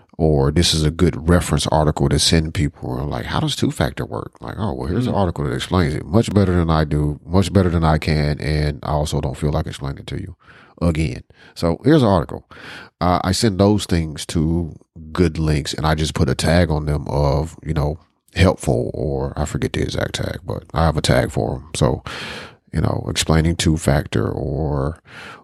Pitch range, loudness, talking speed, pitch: 75-85 Hz, -19 LUFS, 215 wpm, 80 Hz